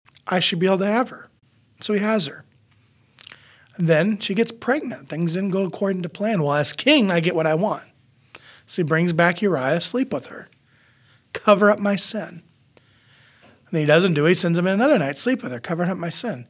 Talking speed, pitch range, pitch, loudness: 220 wpm, 140-205 Hz, 175 Hz, -21 LUFS